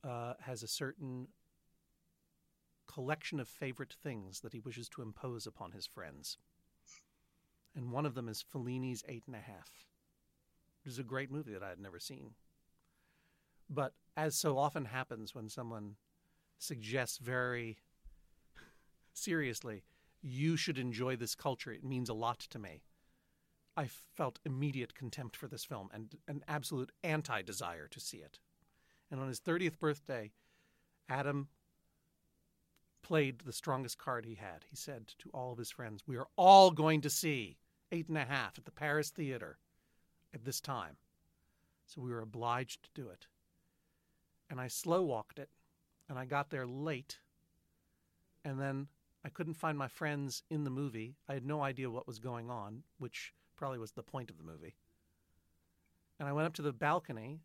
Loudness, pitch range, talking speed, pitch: -38 LUFS, 110-145 Hz, 165 wpm, 130 Hz